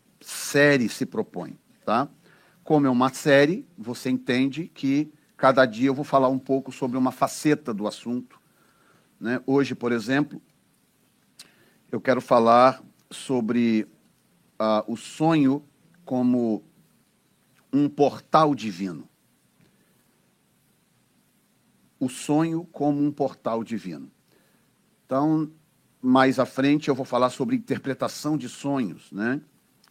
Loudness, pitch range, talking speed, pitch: -24 LUFS, 125-145 Hz, 110 wpm, 135 Hz